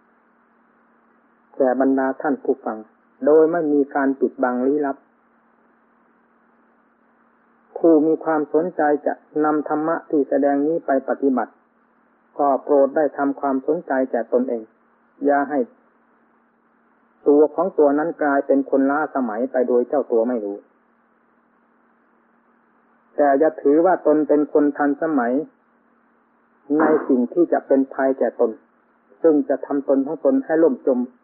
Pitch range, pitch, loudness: 135-155 Hz, 145 Hz, -20 LUFS